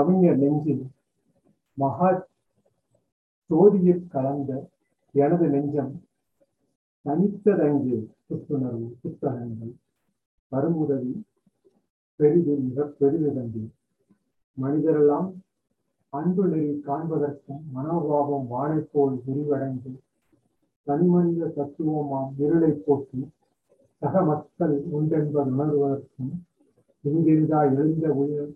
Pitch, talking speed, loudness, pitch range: 145 Hz, 60 wpm, -24 LUFS, 140-160 Hz